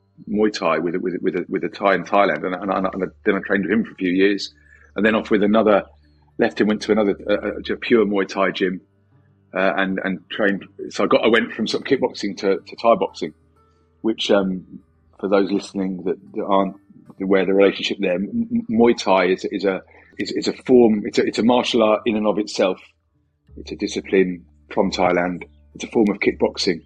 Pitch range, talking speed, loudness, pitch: 90-105 Hz, 220 wpm, -20 LUFS, 95 Hz